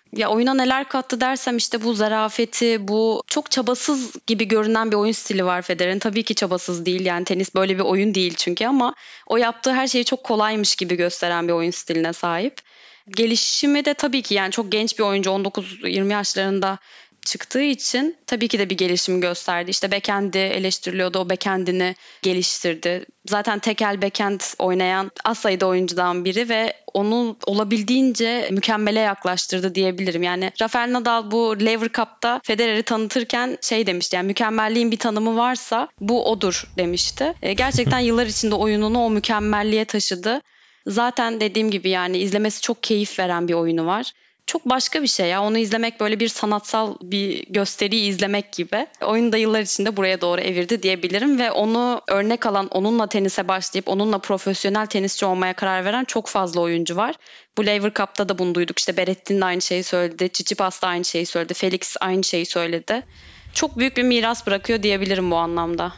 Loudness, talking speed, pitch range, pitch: -21 LUFS, 165 wpm, 185-230 Hz, 205 Hz